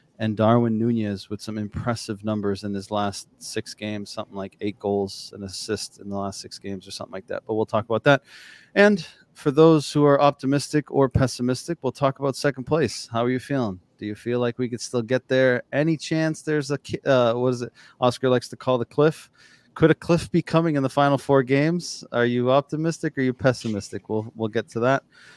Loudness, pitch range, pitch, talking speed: -23 LUFS, 110-140 Hz, 125 Hz, 220 wpm